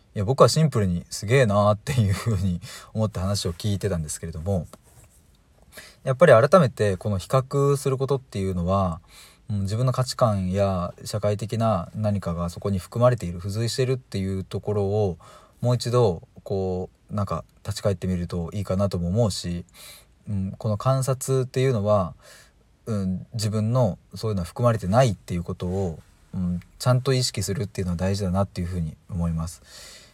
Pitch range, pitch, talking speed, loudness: 95-120 Hz, 100 Hz, 375 characters per minute, -24 LUFS